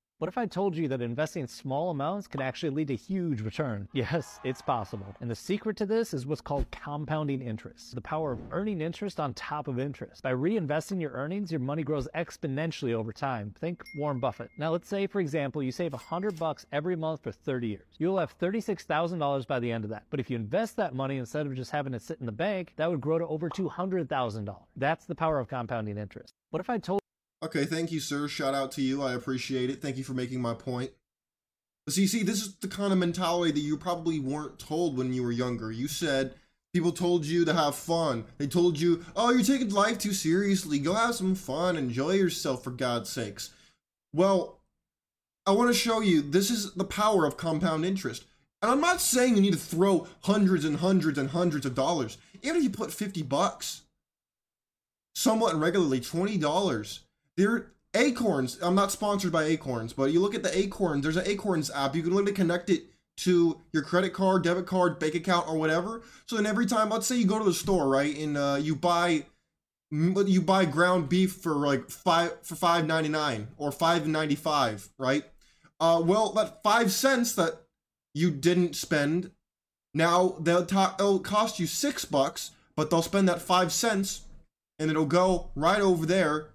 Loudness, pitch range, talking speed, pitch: -28 LUFS, 140-190 Hz, 205 wpm, 165 Hz